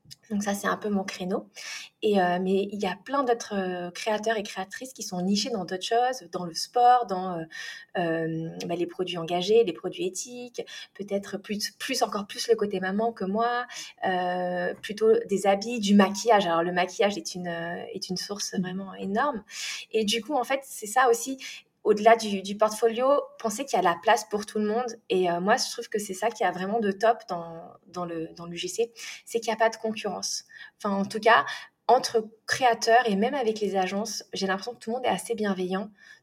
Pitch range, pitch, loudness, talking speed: 185-230 Hz, 210 Hz, -27 LUFS, 220 wpm